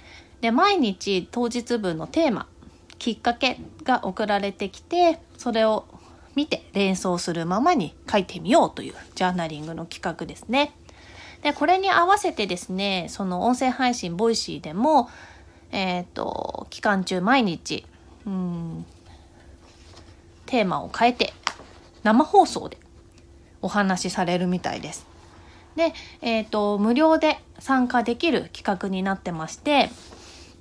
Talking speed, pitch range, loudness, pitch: 260 characters per minute, 175-250 Hz, -24 LUFS, 205 Hz